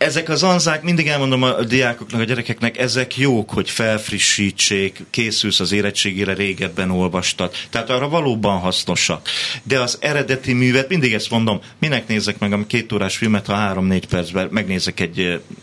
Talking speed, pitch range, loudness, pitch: 155 wpm, 100-130 Hz, -18 LUFS, 110 Hz